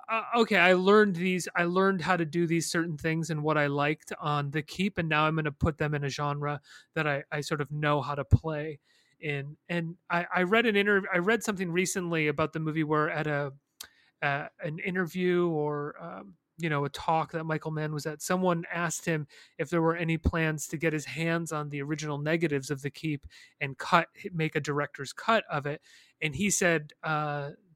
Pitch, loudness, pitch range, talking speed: 160 Hz, -29 LUFS, 150-175 Hz, 220 wpm